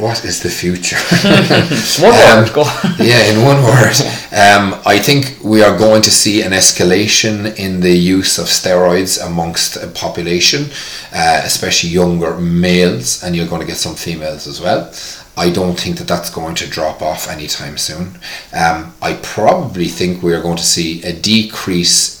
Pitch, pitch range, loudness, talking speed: 90 Hz, 85-110 Hz, -11 LUFS, 170 wpm